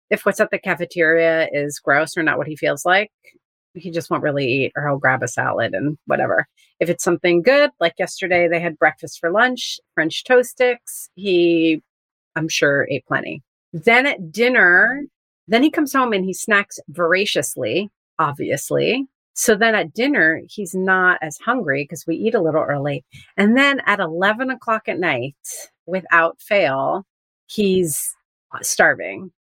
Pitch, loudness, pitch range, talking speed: 180 Hz, -18 LUFS, 160-220 Hz, 165 wpm